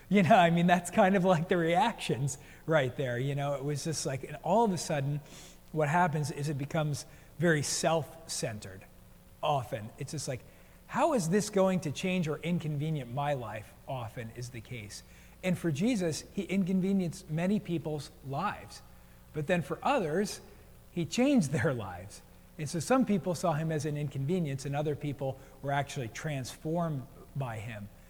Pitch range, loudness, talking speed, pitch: 140-175 Hz, -31 LUFS, 175 wpm, 155 Hz